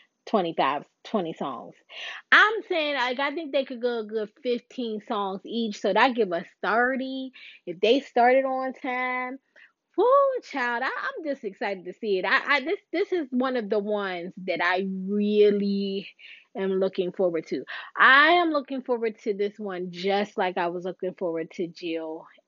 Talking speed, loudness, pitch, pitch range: 175 wpm, -25 LUFS, 225 Hz, 190-265 Hz